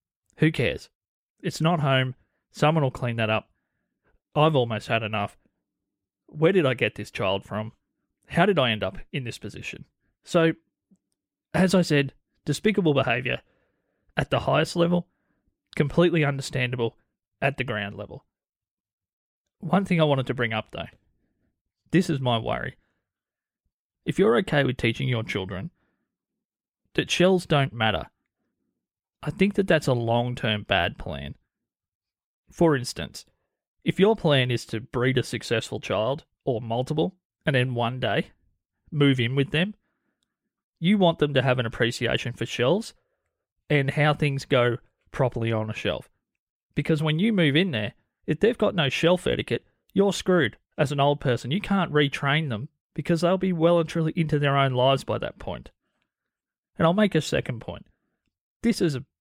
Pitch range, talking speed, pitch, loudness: 115-165 Hz, 160 wpm, 140 Hz, -24 LUFS